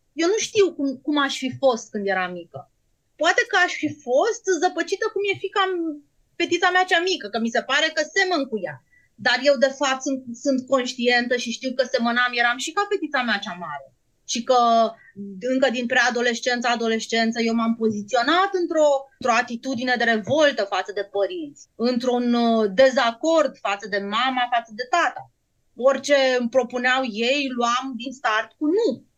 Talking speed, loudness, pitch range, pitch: 175 wpm, -21 LUFS, 235-300 Hz, 255 Hz